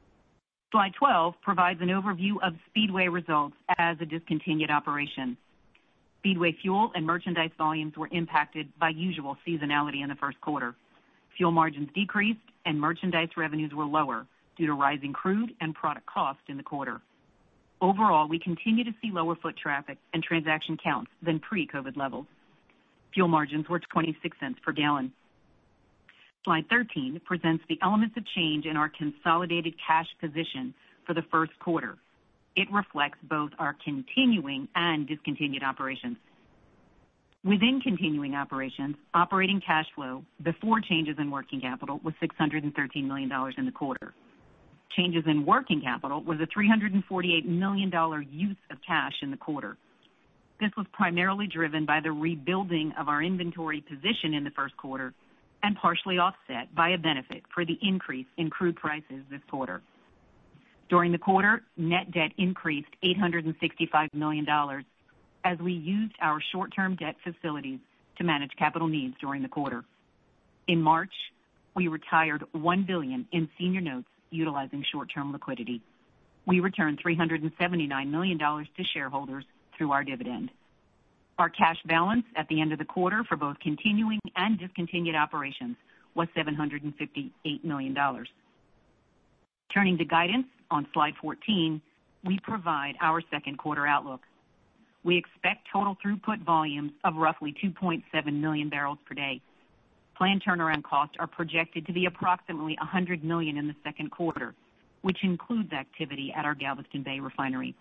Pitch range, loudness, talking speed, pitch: 150-185 Hz, -29 LUFS, 145 wpm, 165 Hz